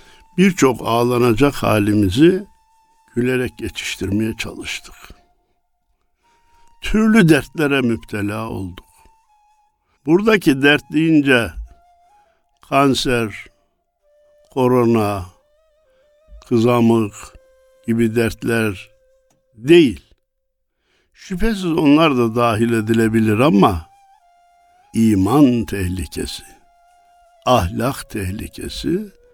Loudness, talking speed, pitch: -17 LUFS, 60 wpm, 145 Hz